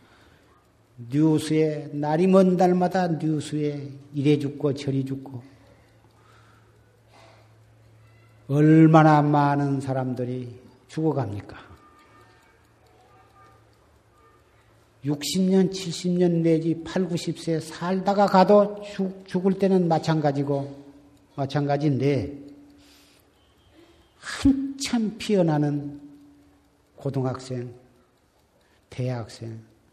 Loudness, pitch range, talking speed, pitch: -23 LUFS, 115-160 Hz, 145 characters per minute, 140 Hz